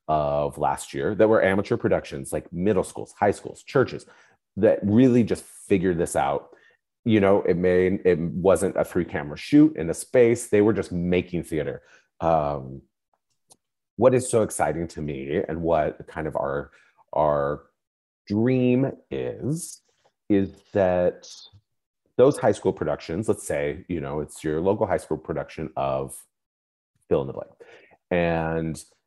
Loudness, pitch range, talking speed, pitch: -24 LUFS, 75-105 Hz, 150 wpm, 90 Hz